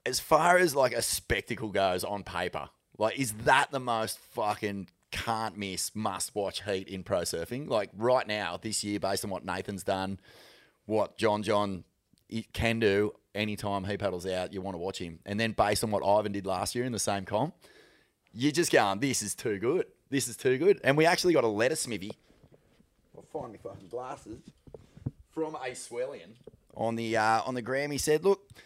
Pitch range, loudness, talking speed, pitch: 95-125 Hz, -30 LUFS, 195 wpm, 105 Hz